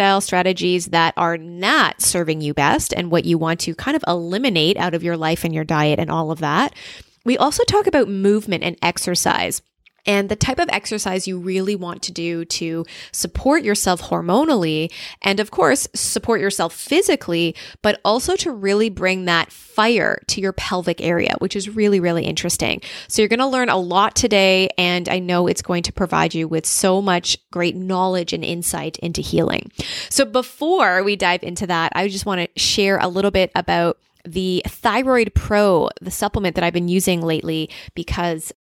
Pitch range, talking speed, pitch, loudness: 170-210 Hz, 185 wpm, 185 Hz, -19 LUFS